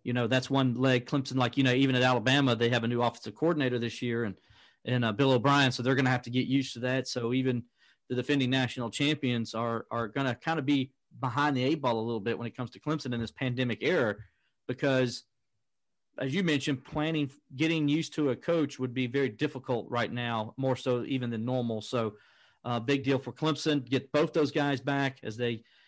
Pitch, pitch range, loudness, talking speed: 130 Hz, 120-140 Hz, -30 LUFS, 230 wpm